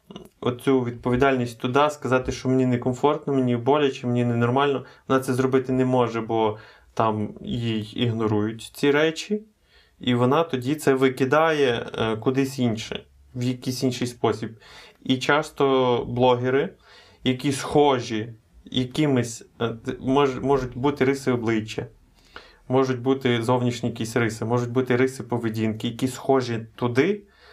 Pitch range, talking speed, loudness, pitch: 120-135 Hz, 120 wpm, -23 LUFS, 125 Hz